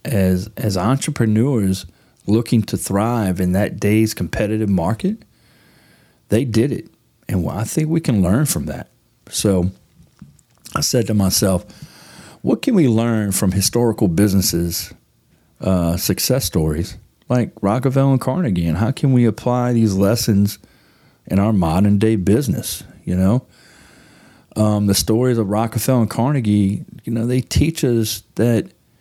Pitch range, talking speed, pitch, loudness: 95-120 Hz, 145 wpm, 110 Hz, -18 LUFS